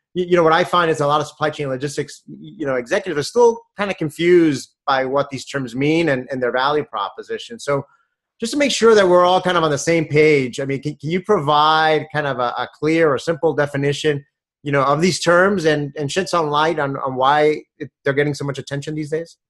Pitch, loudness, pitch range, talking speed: 150 Hz, -18 LUFS, 140-175 Hz, 245 wpm